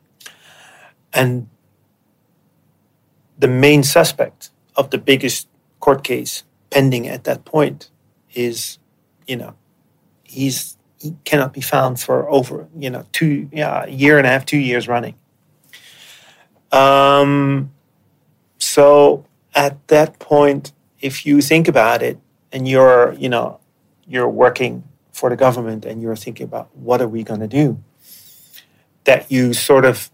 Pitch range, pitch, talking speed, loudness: 125-145 Hz, 135 Hz, 135 wpm, -15 LUFS